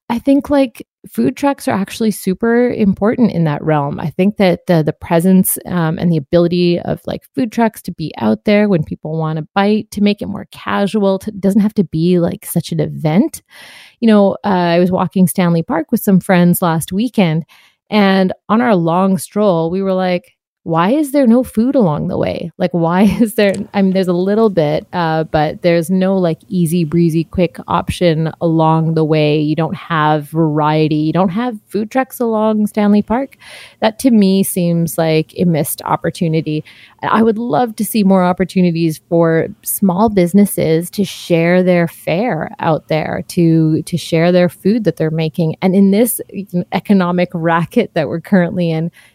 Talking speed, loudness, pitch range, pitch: 185 wpm, -14 LUFS, 165-205 Hz, 185 Hz